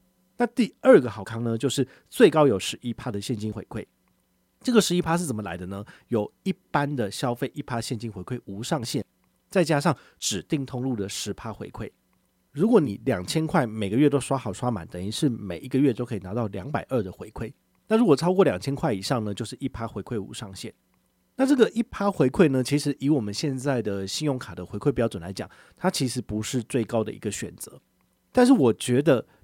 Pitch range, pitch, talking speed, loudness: 105-145 Hz, 125 Hz, 310 characters per minute, -25 LUFS